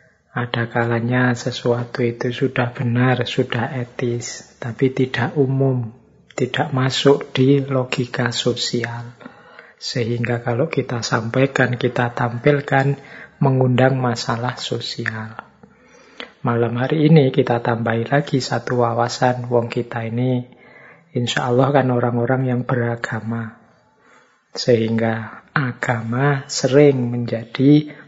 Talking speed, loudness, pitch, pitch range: 100 wpm, -19 LUFS, 125 Hz, 120-135 Hz